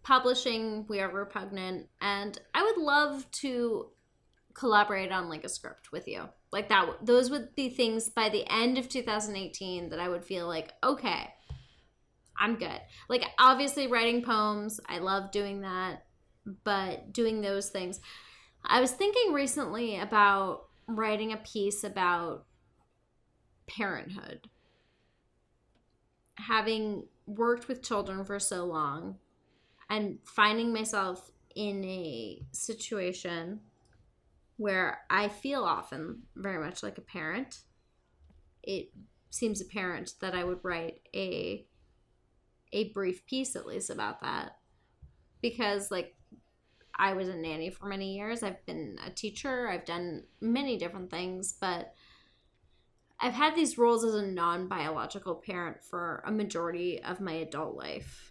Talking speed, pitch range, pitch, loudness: 130 wpm, 180-230 Hz, 200 Hz, -32 LUFS